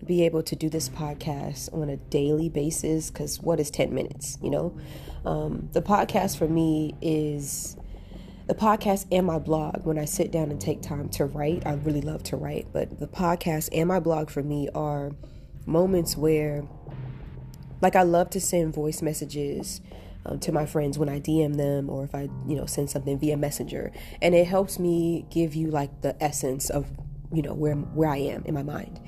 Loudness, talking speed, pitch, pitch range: -27 LUFS, 200 wpm, 150 Hz, 145-165 Hz